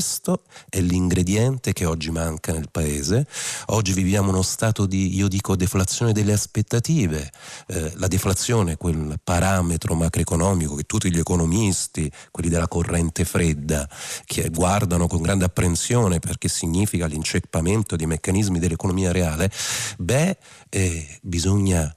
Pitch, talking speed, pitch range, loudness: 90 Hz, 130 wpm, 85-100 Hz, -22 LUFS